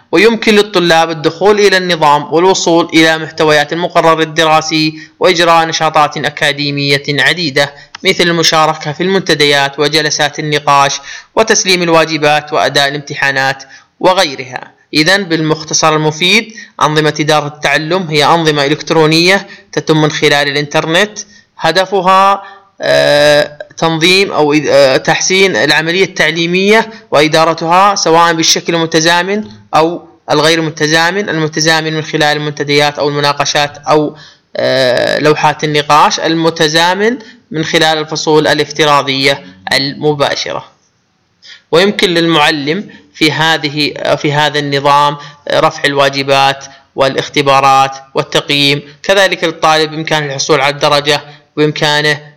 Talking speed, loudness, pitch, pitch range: 95 wpm, -10 LUFS, 155 Hz, 145-170 Hz